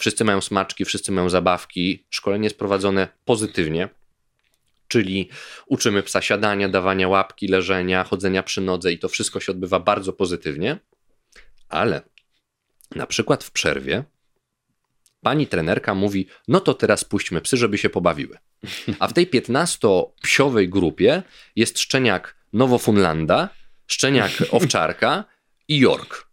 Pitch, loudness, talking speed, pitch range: 100 Hz, -20 LUFS, 125 wpm, 95-105 Hz